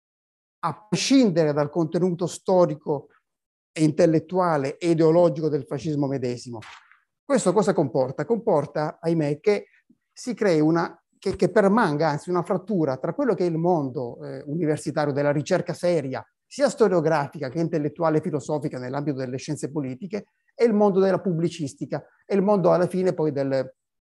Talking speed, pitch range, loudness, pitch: 150 wpm, 150-185 Hz, -23 LUFS, 165 Hz